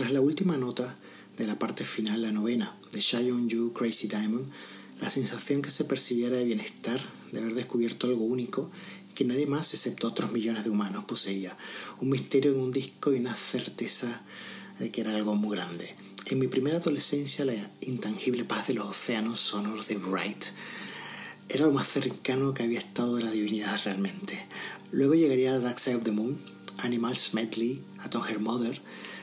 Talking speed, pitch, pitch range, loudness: 175 wpm, 120 Hz, 110-130 Hz, -27 LUFS